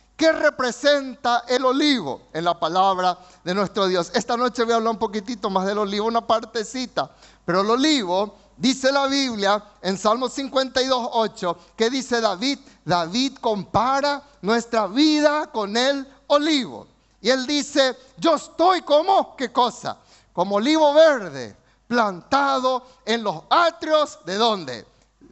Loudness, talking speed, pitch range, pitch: -21 LUFS, 140 wpm, 205-275 Hz, 240 Hz